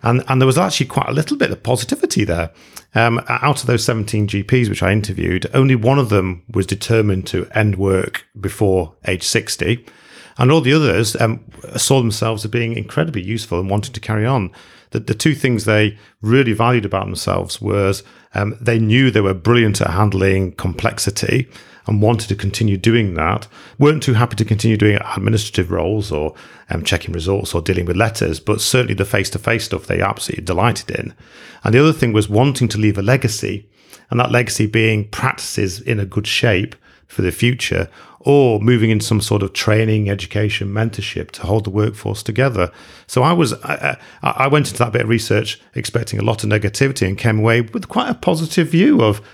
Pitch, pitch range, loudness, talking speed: 110 Hz, 100-120 Hz, -17 LUFS, 195 wpm